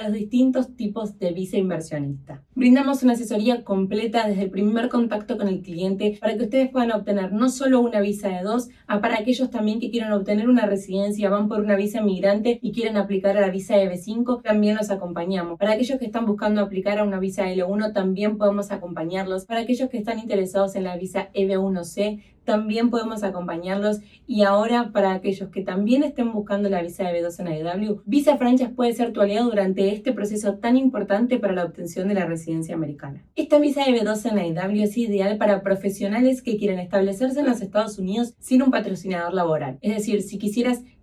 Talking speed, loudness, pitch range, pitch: 195 wpm, -23 LUFS, 195-235 Hz, 205 Hz